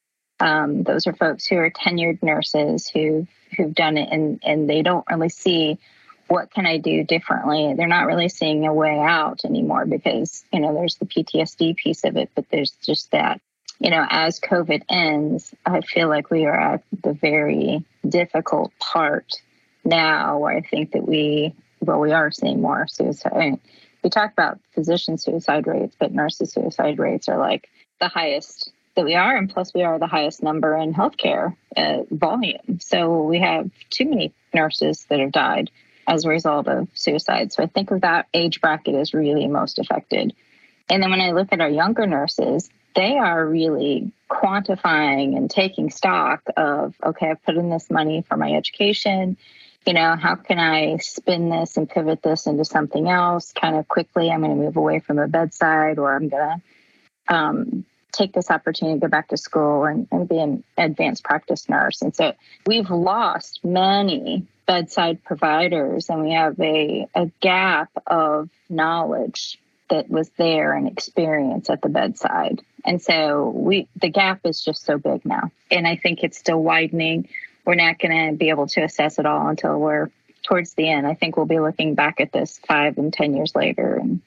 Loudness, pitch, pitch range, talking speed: -20 LUFS, 165 Hz, 155-180 Hz, 185 wpm